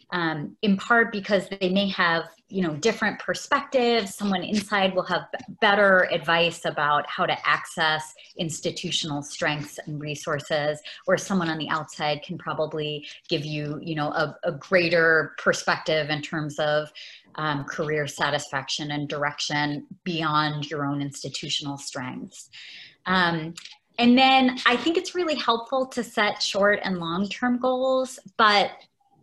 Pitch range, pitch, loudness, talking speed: 150-205 Hz, 170 Hz, -24 LUFS, 145 wpm